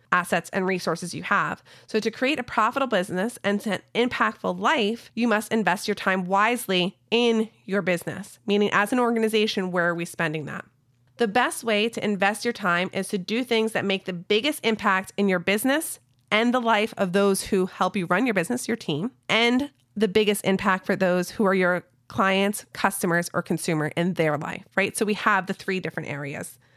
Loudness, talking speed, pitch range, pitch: -24 LUFS, 200 wpm, 180-220 Hz, 200 Hz